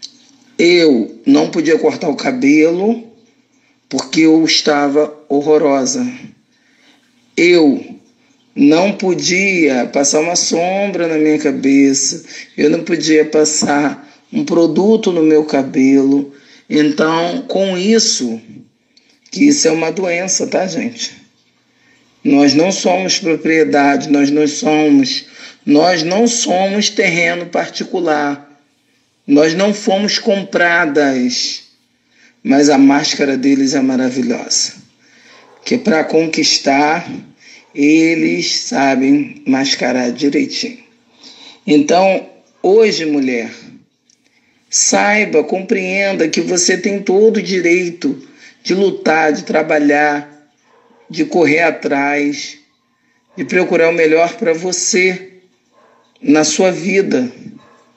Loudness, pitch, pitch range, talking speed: -13 LUFS, 170 Hz, 145-215 Hz, 95 wpm